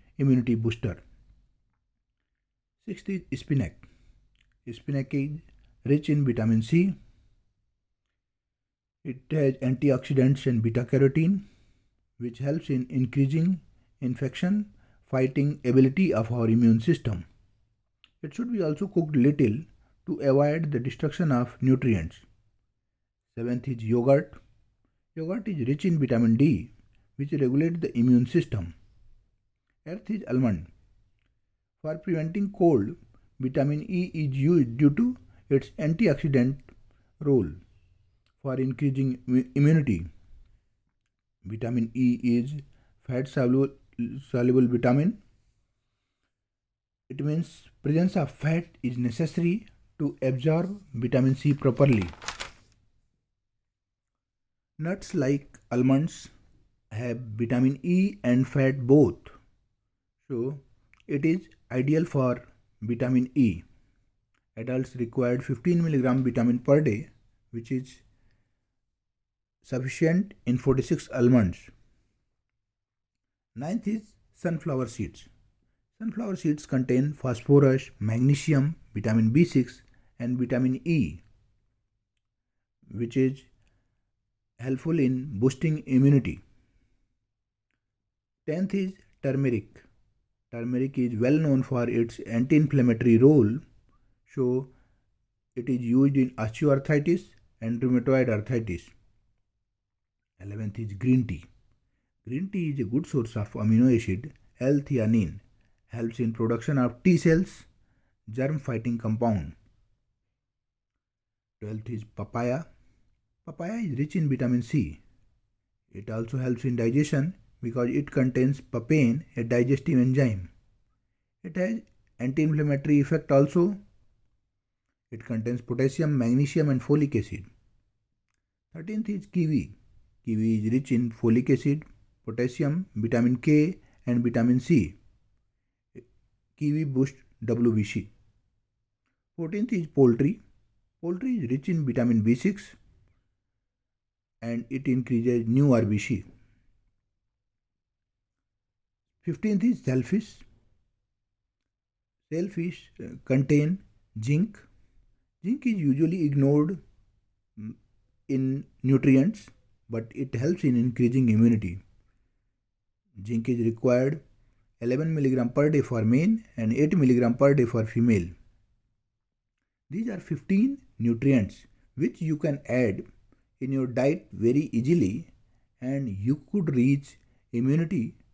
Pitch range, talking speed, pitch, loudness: 110-140 Hz, 100 wpm, 120 Hz, -26 LUFS